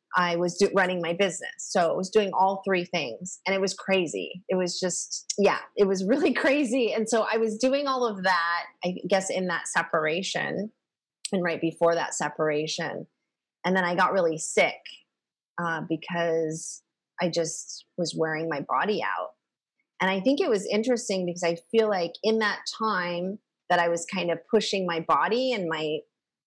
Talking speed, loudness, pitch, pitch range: 185 wpm, -26 LUFS, 185 Hz, 170-210 Hz